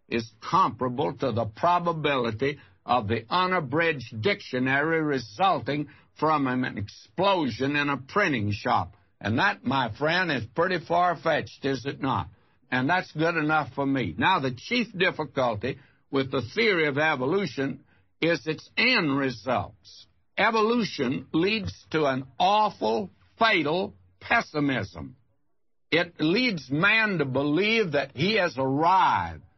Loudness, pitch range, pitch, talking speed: -25 LUFS, 125-170 Hz, 140 Hz, 130 wpm